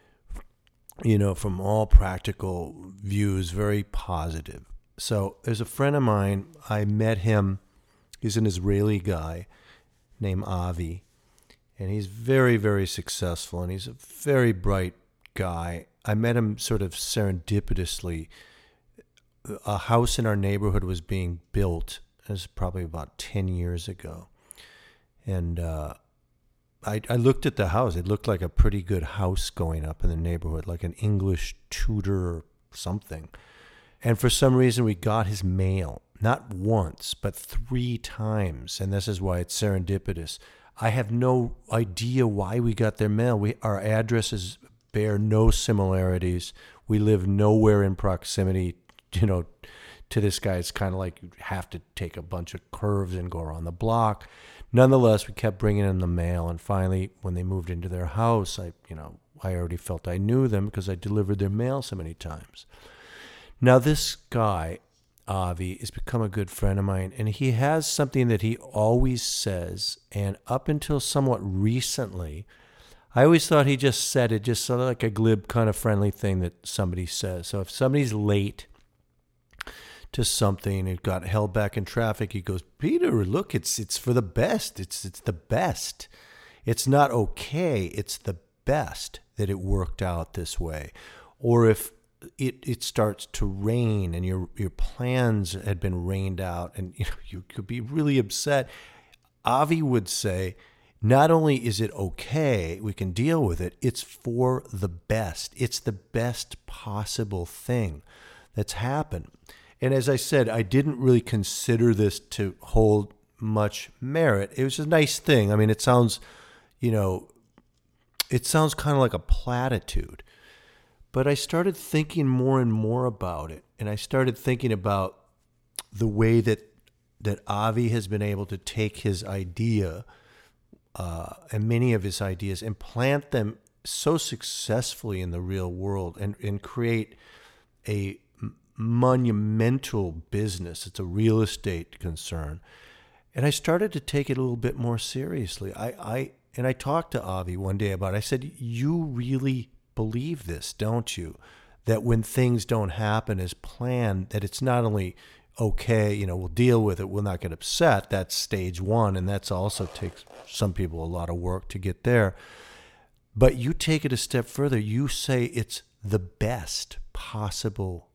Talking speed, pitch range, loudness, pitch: 165 wpm, 95-120 Hz, -26 LUFS, 105 Hz